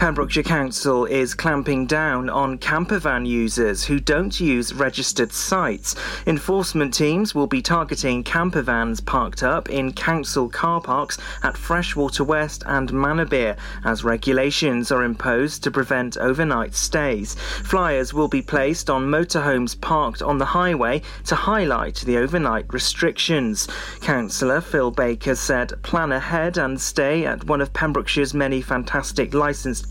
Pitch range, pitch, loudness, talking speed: 125-155 Hz, 140 Hz, -21 LUFS, 135 wpm